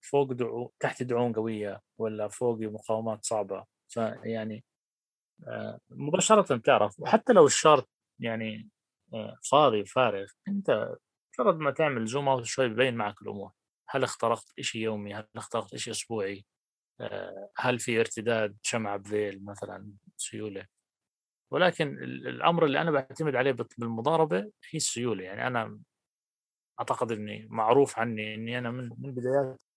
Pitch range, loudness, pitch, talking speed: 105-130 Hz, -28 LUFS, 115 Hz, 125 wpm